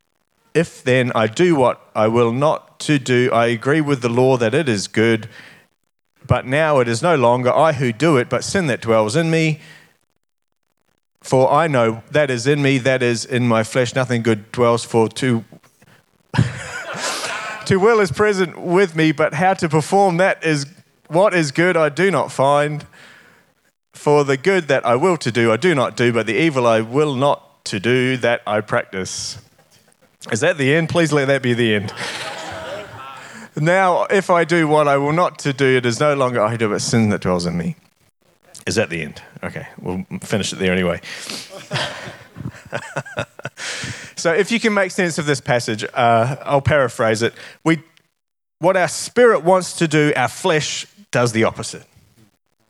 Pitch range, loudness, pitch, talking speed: 120-165 Hz, -17 LUFS, 140 Hz, 185 wpm